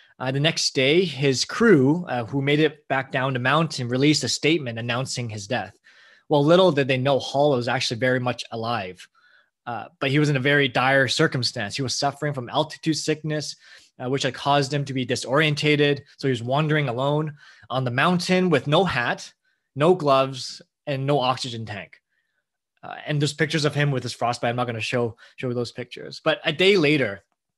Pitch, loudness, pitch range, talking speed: 140 Hz, -22 LUFS, 125-150 Hz, 200 wpm